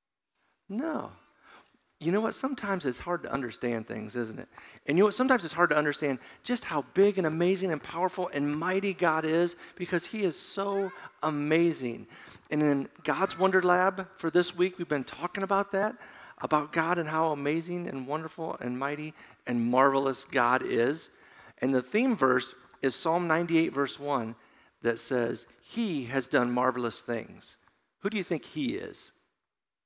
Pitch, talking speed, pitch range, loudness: 160 Hz, 170 wpm, 135-185 Hz, -29 LUFS